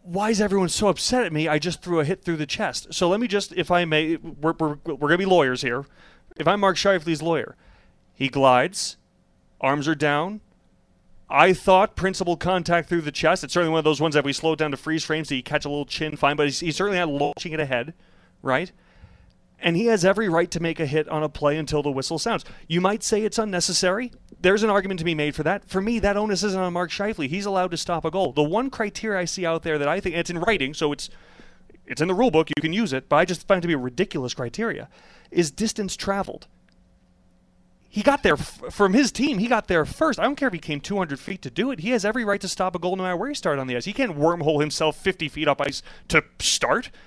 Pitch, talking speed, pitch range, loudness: 170 Hz, 260 wpm, 150-195 Hz, -23 LUFS